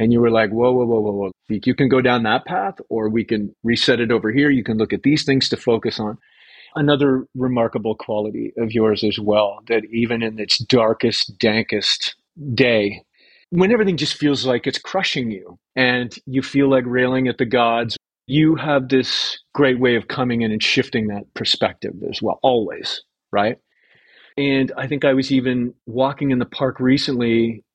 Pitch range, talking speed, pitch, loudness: 110-135 Hz, 190 wpm, 125 Hz, -19 LUFS